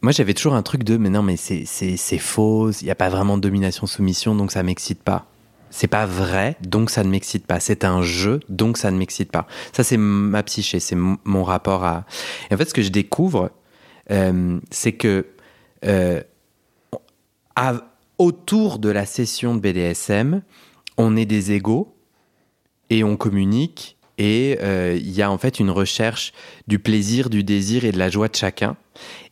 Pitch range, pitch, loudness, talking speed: 95-110 Hz, 105 Hz, -20 LUFS, 190 wpm